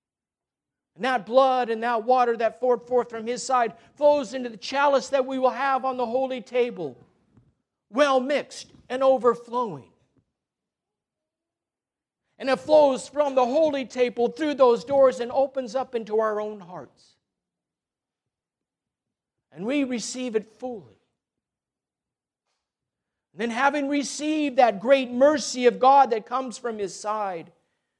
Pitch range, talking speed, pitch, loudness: 230-270 Hz, 135 wpm, 250 Hz, -23 LUFS